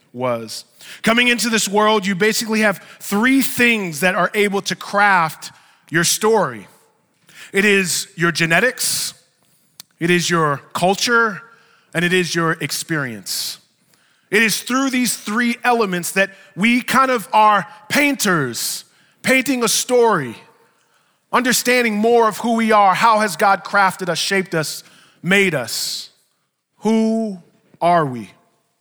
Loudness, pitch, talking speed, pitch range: -17 LUFS, 200 Hz, 130 wpm, 170-230 Hz